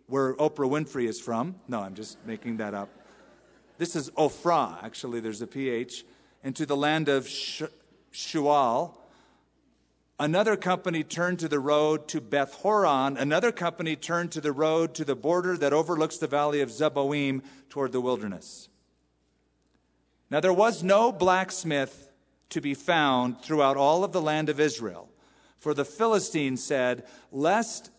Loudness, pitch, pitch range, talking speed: -27 LUFS, 145 Hz, 130-165 Hz, 150 wpm